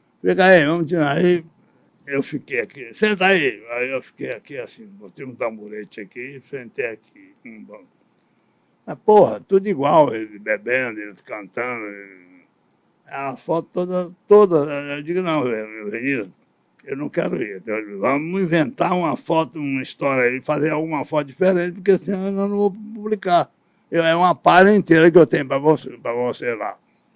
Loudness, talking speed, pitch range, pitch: -19 LUFS, 165 wpm, 130-185 Hz, 160 Hz